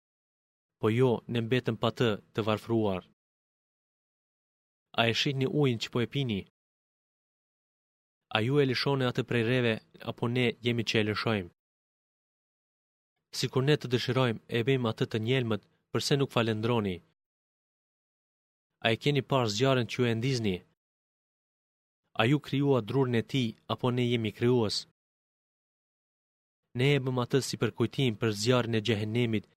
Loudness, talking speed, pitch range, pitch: -29 LUFS, 145 wpm, 110-130 Hz, 120 Hz